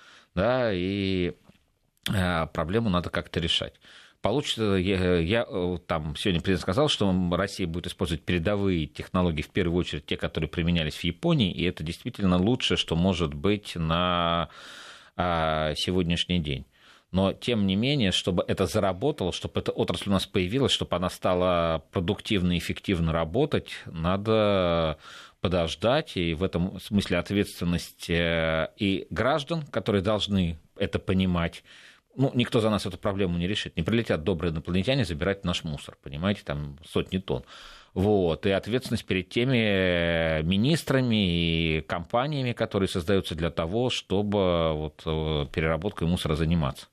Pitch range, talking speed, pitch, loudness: 85-100 Hz, 135 wpm, 90 Hz, -27 LUFS